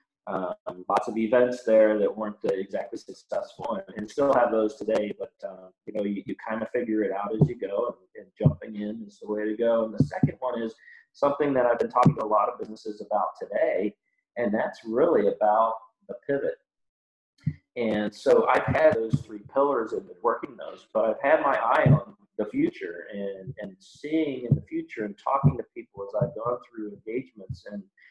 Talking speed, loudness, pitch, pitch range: 205 wpm, -26 LUFS, 120 Hz, 110-155 Hz